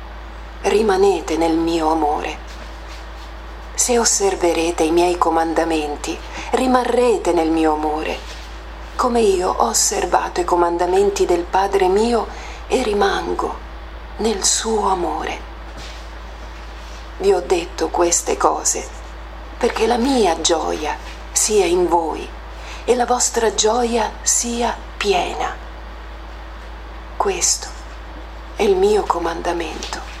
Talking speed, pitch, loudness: 100 wpm, 165 Hz, -18 LUFS